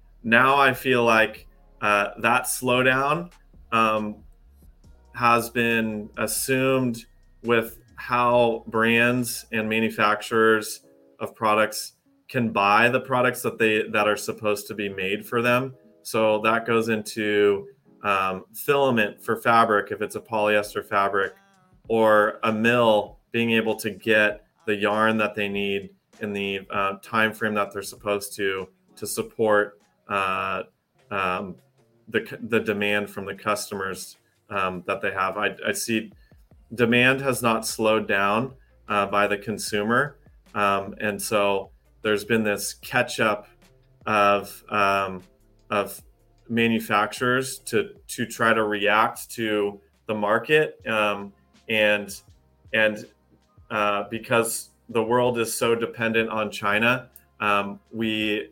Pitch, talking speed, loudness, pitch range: 110 Hz, 130 wpm, -23 LUFS, 100-115 Hz